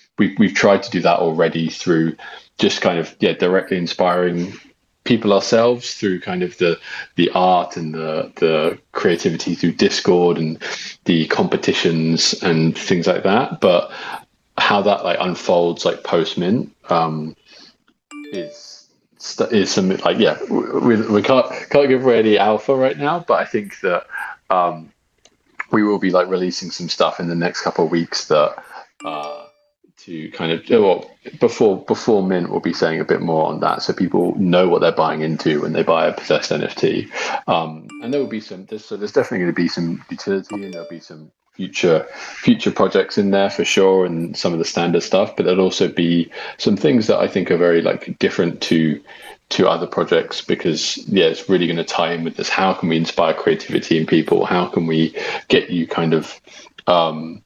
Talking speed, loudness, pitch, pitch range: 190 wpm, -18 LUFS, 85 Hz, 80-100 Hz